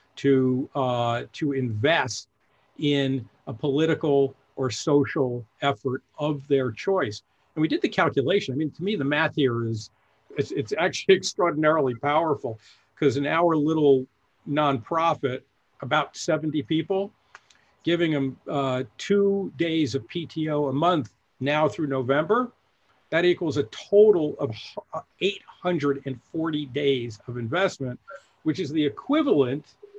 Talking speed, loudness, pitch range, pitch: 130 wpm, -25 LUFS, 130-160 Hz, 145 Hz